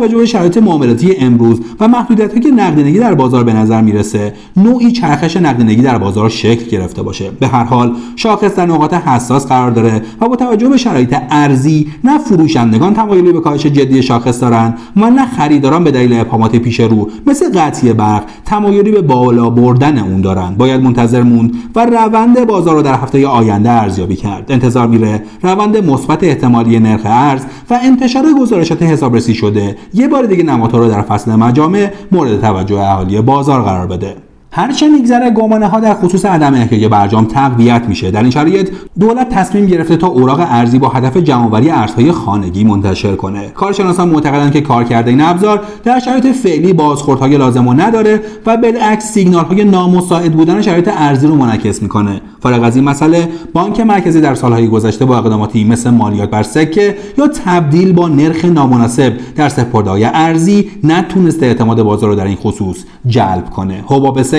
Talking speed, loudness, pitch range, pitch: 175 wpm, -10 LUFS, 115-185 Hz, 135 Hz